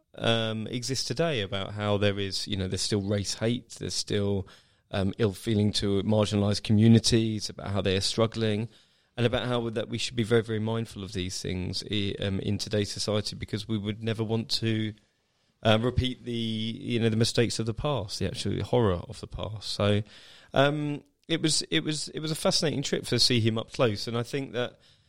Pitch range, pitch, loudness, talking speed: 100-120 Hz, 110 Hz, -28 LUFS, 205 wpm